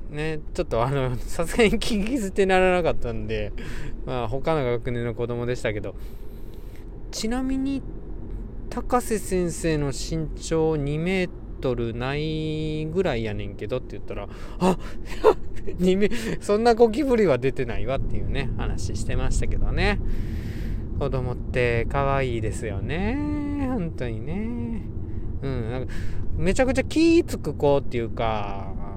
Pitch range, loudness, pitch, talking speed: 110-170 Hz, -25 LUFS, 125 Hz, 275 characters per minute